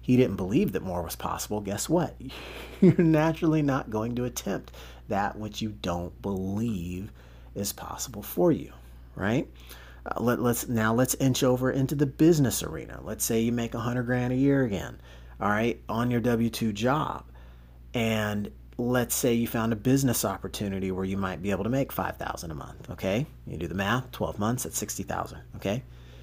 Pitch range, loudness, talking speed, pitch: 95-125 Hz, -28 LUFS, 190 wpm, 110 Hz